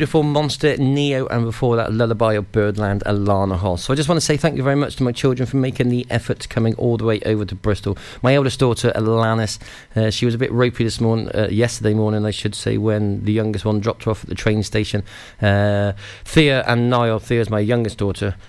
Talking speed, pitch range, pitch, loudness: 235 wpm, 105-125 Hz, 115 Hz, -19 LUFS